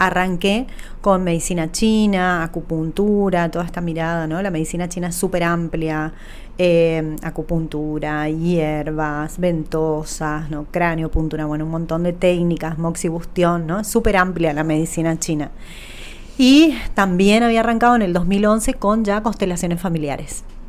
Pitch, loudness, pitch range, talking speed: 170 Hz, -19 LUFS, 160-190 Hz, 130 wpm